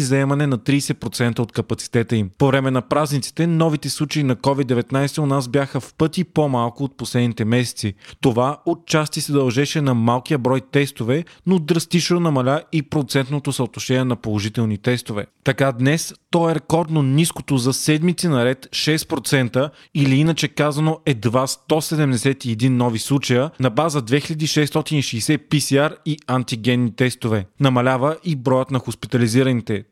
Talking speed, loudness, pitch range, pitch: 140 wpm, -19 LUFS, 125-155 Hz, 135 Hz